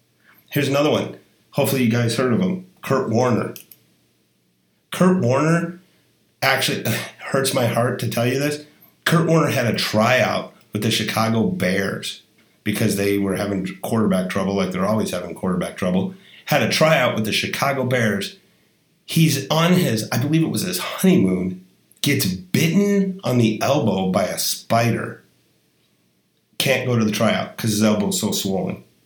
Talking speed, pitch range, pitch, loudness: 160 wpm, 105-155 Hz, 120 Hz, -20 LUFS